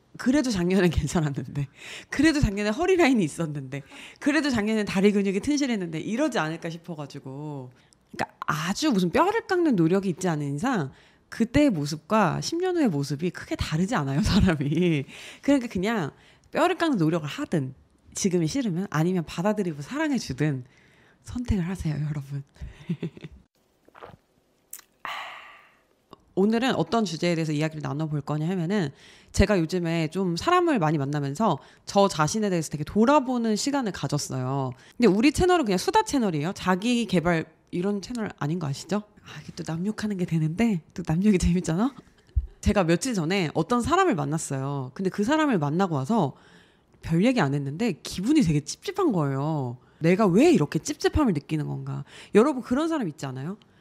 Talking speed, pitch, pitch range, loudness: 355 characters per minute, 180 Hz, 155-235 Hz, -25 LUFS